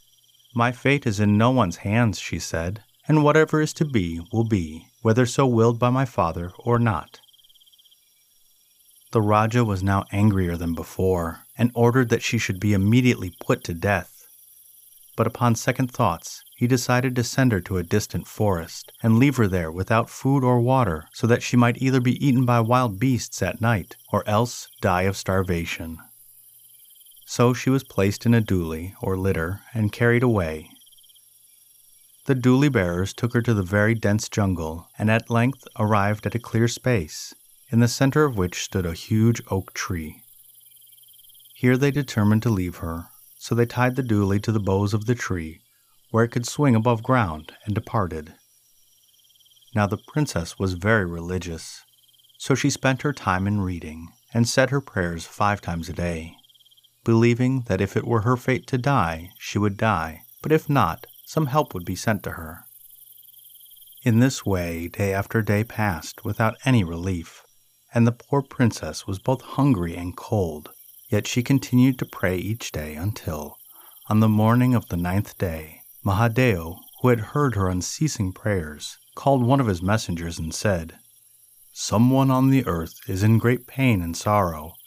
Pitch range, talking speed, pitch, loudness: 95-125 Hz, 175 wpm, 115 Hz, -23 LUFS